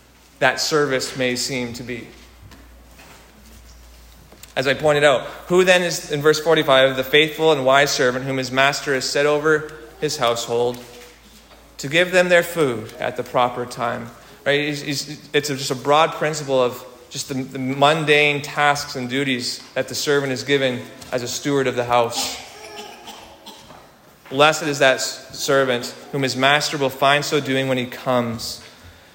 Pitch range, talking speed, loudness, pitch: 125-145 Hz, 155 wpm, -19 LUFS, 135 Hz